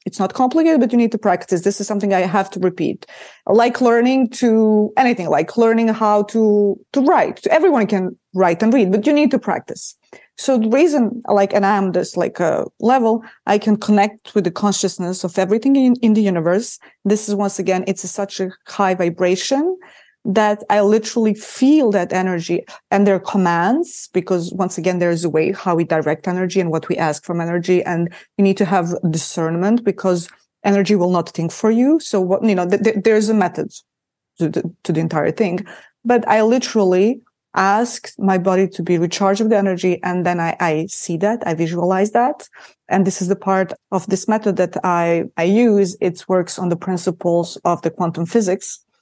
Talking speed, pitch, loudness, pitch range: 205 wpm, 195 Hz, -17 LUFS, 180-220 Hz